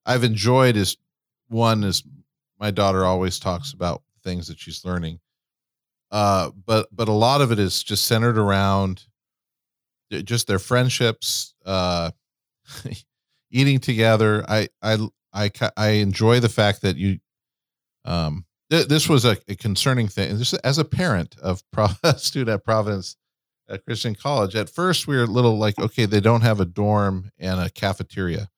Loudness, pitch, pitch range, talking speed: -21 LUFS, 105 Hz, 95-120 Hz, 160 wpm